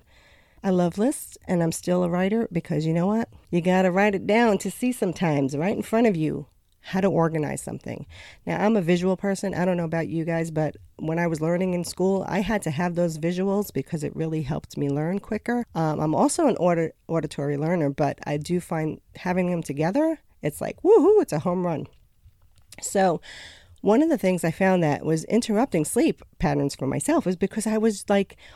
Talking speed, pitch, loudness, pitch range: 210 wpm, 175 Hz, -24 LUFS, 155-200 Hz